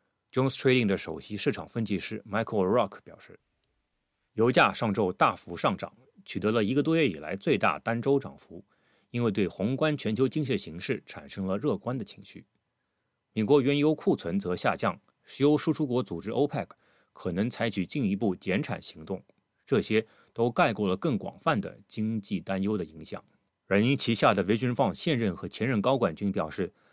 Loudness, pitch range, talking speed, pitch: -28 LUFS, 100-135 Hz, 330 characters per minute, 110 Hz